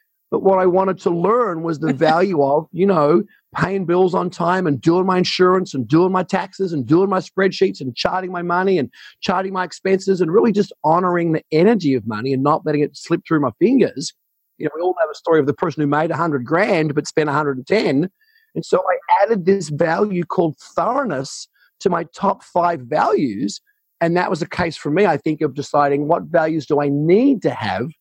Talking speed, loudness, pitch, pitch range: 220 wpm, -18 LUFS, 175 Hz, 155-190 Hz